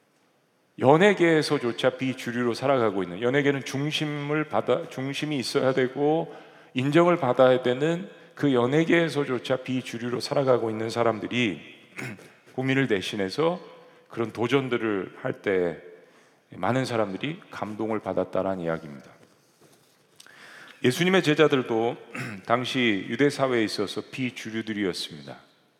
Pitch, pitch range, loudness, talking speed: 125 Hz, 110-145 Hz, -25 LUFS, 295 characters per minute